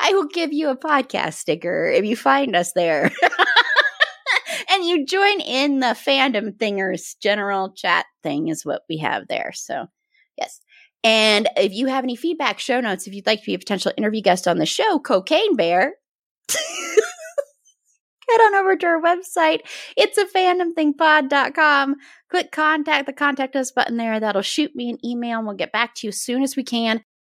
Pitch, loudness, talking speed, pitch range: 275 Hz, -19 LUFS, 185 wpm, 220-335 Hz